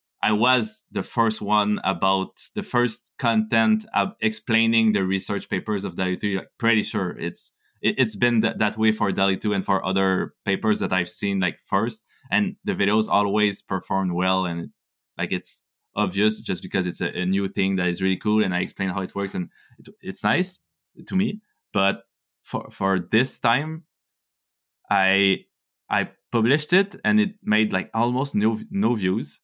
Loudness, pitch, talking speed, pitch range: -23 LUFS, 105 Hz, 180 wpm, 95-115 Hz